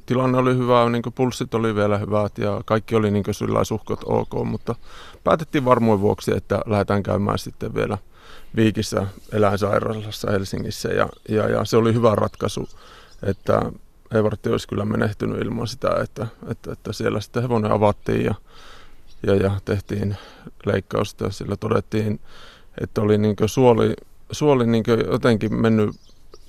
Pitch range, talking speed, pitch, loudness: 105-115 Hz, 145 wpm, 110 Hz, -22 LUFS